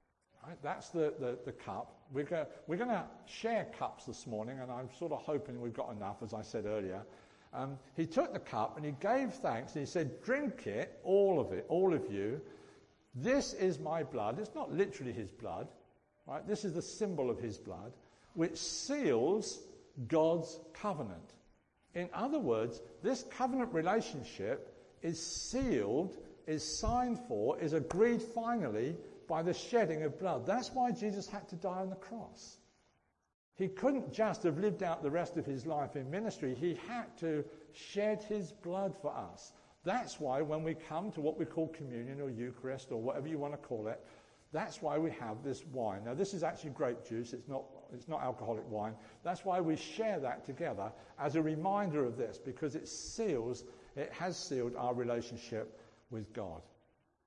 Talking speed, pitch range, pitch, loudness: 180 wpm, 130-205 Hz, 160 Hz, -38 LUFS